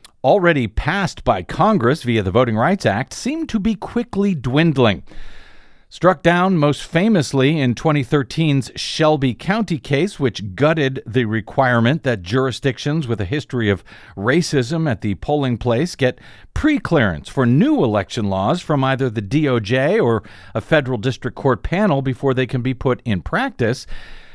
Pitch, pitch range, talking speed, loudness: 130 Hz, 115-155 Hz, 150 wpm, -18 LUFS